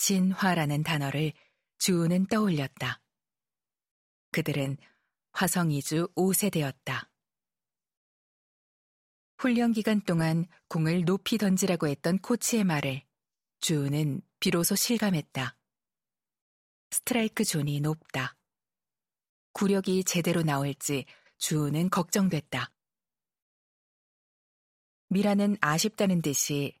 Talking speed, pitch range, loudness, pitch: 200 characters per minute, 150-200 Hz, -28 LUFS, 175 Hz